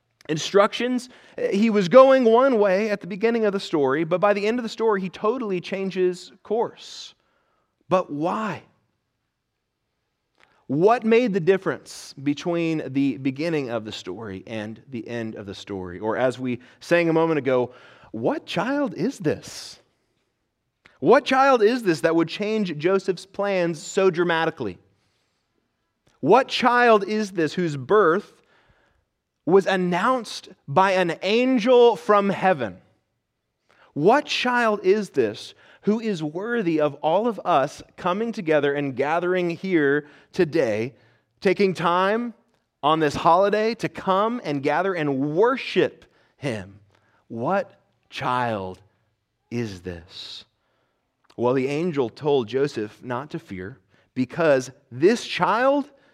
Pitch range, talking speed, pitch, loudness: 130-205 Hz, 130 wpm, 170 Hz, -22 LUFS